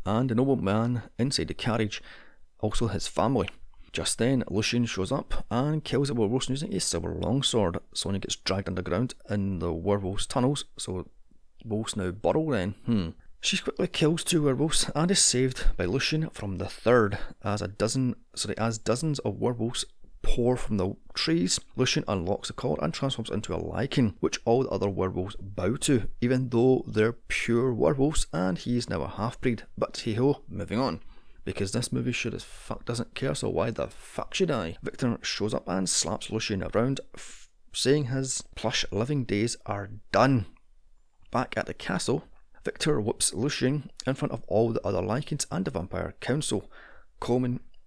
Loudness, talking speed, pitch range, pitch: -28 LUFS, 180 wpm, 100-130 Hz, 115 Hz